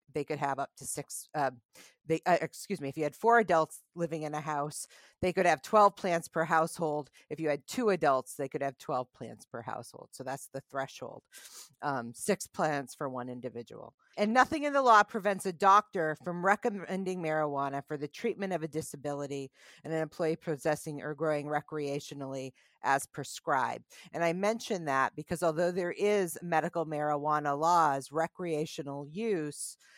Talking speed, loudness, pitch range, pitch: 175 wpm, -32 LUFS, 145-180 Hz, 155 Hz